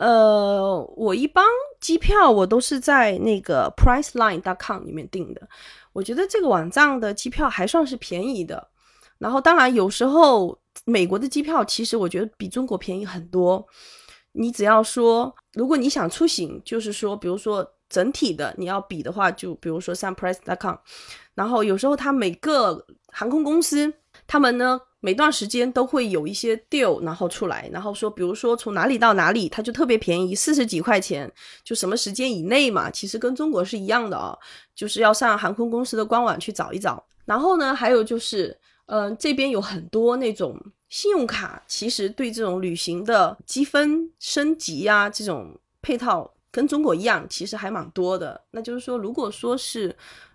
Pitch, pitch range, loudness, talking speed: 230 Hz, 195-275 Hz, -22 LUFS, 310 characters per minute